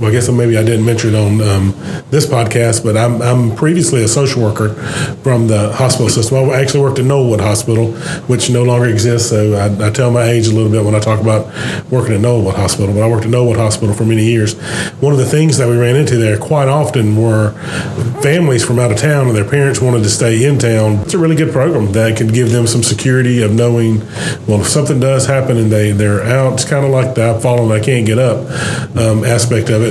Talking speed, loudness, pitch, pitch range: 245 wpm, -12 LUFS, 120 Hz, 110-130 Hz